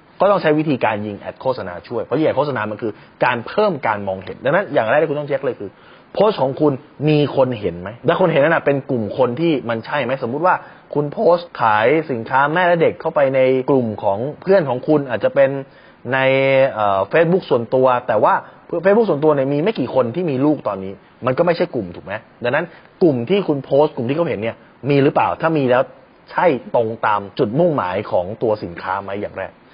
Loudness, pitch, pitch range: -18 LUFS, 135 Hz, 125-155 Hz